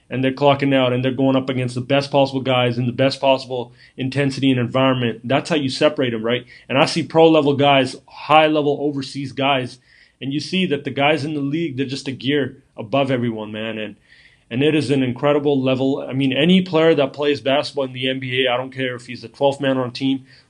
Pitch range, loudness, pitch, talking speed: 130-145 Hz, -19 LUFS, 135 Hz, 235 wpm